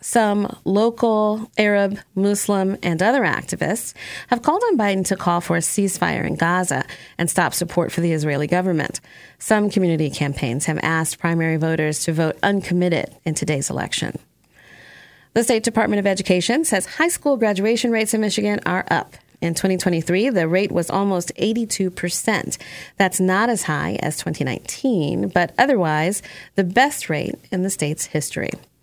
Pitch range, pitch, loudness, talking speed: 165-215 Hz, 190 Hz, -20 LUFS, 155 wpm